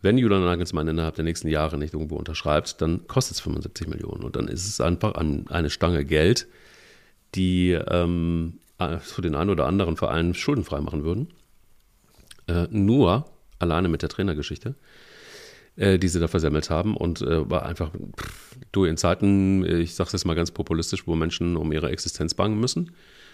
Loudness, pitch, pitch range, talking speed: -24 LUFS, 85 Hz, 80-100 Hz, 170 wpm